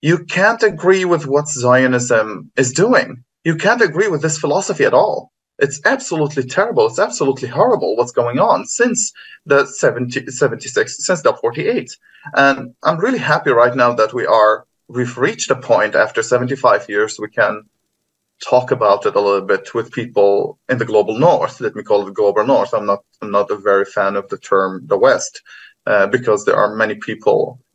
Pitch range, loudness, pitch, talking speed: 115-190 Hz, -15 LUFS, 135 Hz, 195 wpm